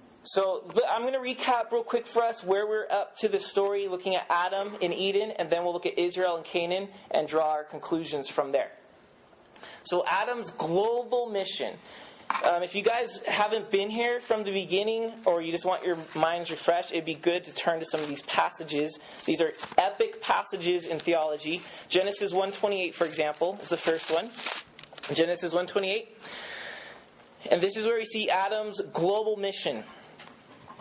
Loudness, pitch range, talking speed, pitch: -28 LUFS, 170-215 Hz, 175 wpm, 190 Hz